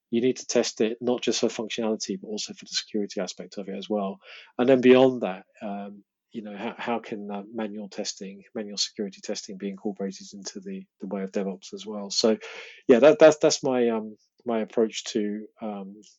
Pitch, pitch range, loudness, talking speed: 110 Hz, 100-125 Hz, -25 LUFS, 210 wpm